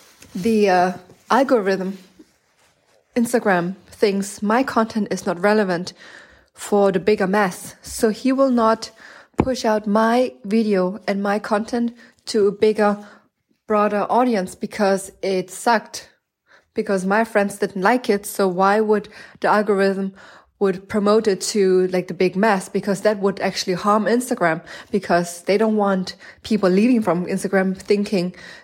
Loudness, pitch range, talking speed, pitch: -20 LUFS, 190-220 Hz, 140 wpm, 205 Hz